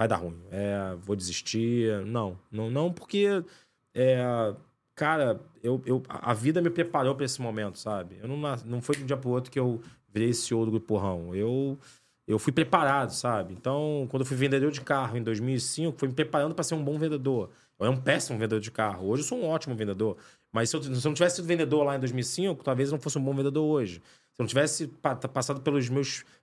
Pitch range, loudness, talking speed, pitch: 115-145 Hz, -29 LUFS, 225 wpm, 130 Hz